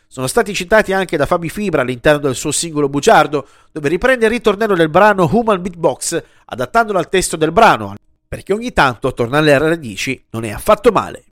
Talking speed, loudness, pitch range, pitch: 185 wpm, -14 LUFS, 140-210 Hz, 170 Hz